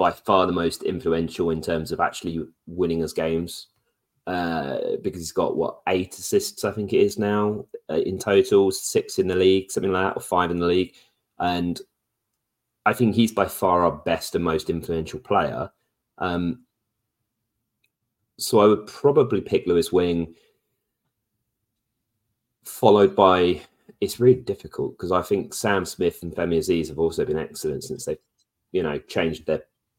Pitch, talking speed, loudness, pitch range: 105 Hz, 165 wpm, -23 LUFS, 85-115 Hz